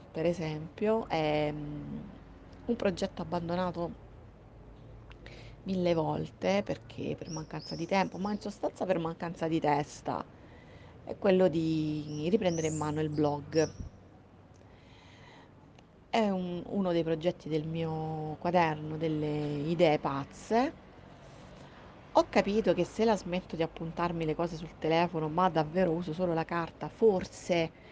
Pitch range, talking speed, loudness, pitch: 150-180 Hz, 125 wpm, -32 LUFS, 165 Hz